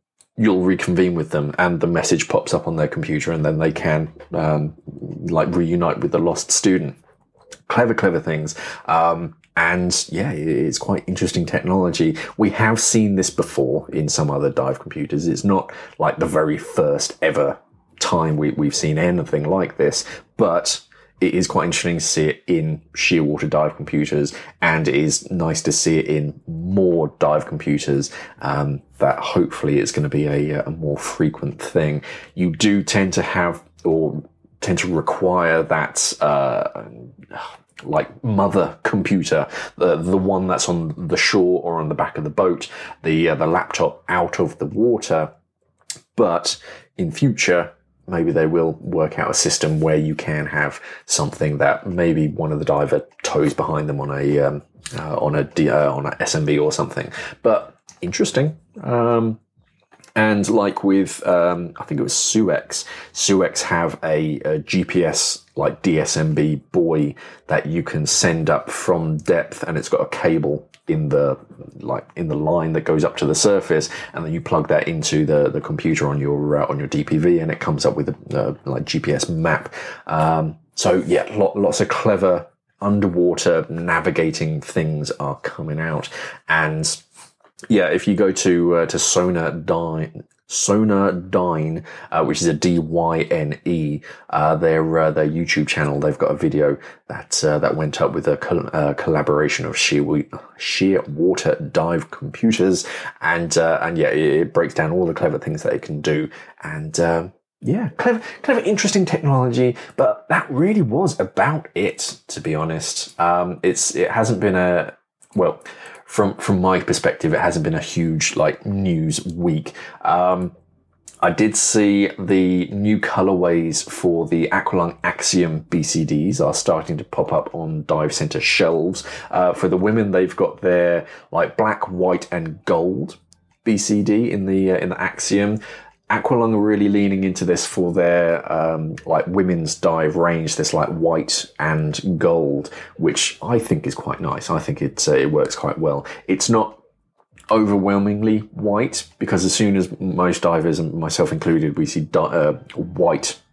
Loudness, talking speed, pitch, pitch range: -19 LUFS, 170 wpm, 85 Hz, 80-100 Hz